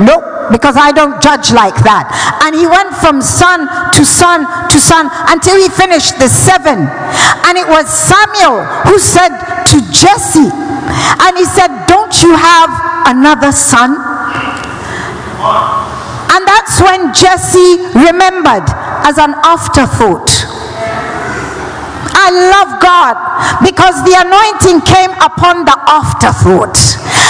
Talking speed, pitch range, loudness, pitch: 125 wpm, 305-370 Hz, -6 LUFS, 345 Hz